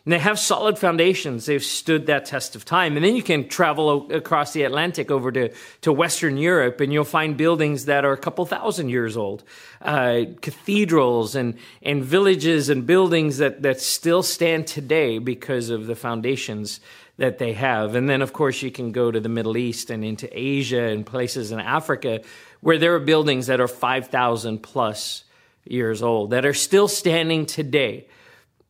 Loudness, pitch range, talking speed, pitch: -21 LUFS, 125-165 Hz, 185 wpm, 140 Hz